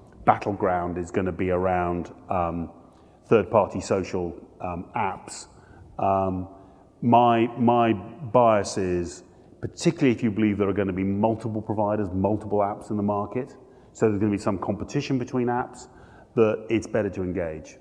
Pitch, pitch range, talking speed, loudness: 105 Hz, 95-115 Hz, 160 wpm, -25 LUFS